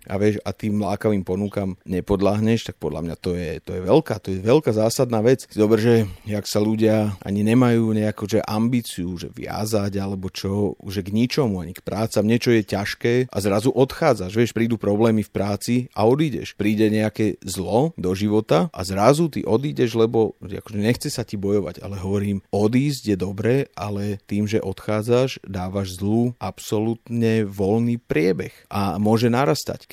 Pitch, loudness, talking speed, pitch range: 105 Hz, -22 LUFS, 170 wpm, 100-115 Hz